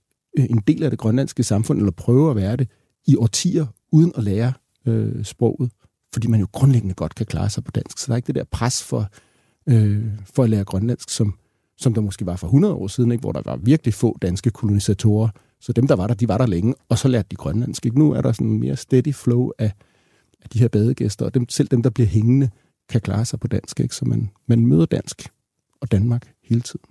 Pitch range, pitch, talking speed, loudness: 105-130 Hz, 120 Hz, 240 wpm, -20 LUFS